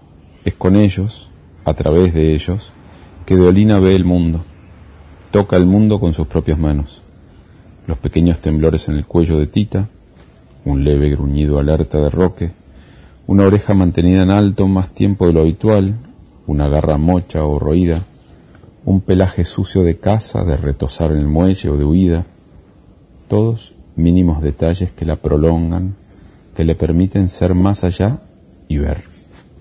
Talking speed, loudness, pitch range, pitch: 150 wpm, -15 LUFS, 75-95 Hz, 85 Hz